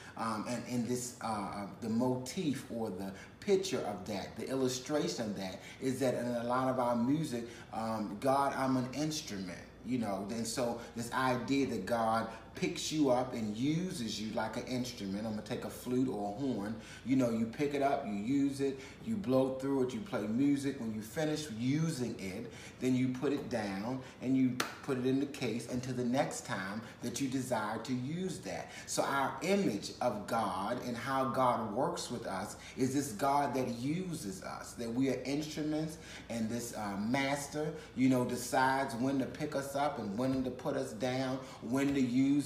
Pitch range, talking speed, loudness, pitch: 120-140 Hz, 200 wpm, -35 LUFS, 130 Hz